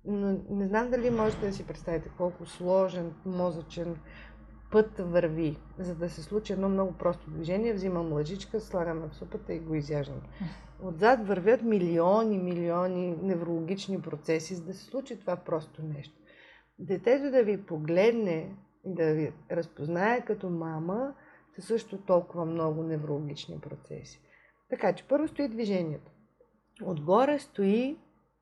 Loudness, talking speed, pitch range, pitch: -30 LUFS, 135 wpm, 165-210 Hz, 185 Hz